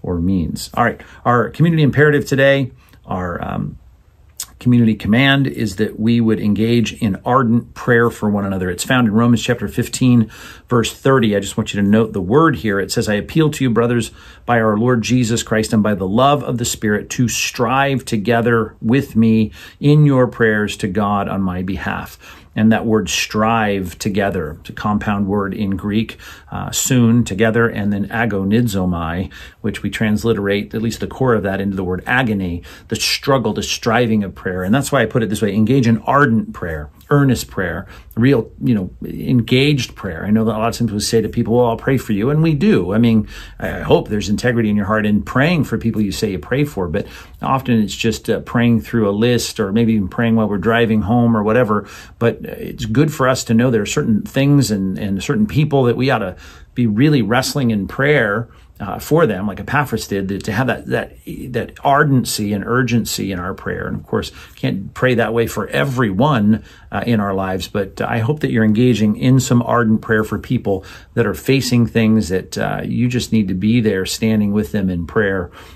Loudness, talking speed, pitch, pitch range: -17 LUFS, 210 wpm, 110 Hz, 100-120 Hz